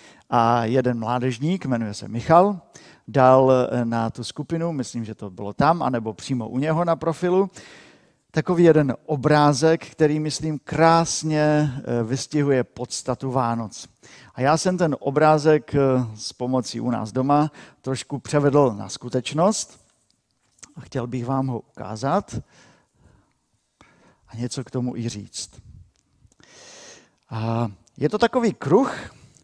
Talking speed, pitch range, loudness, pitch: 125 wpm, 120-155 Hz, -22 LUFS, 130 Hz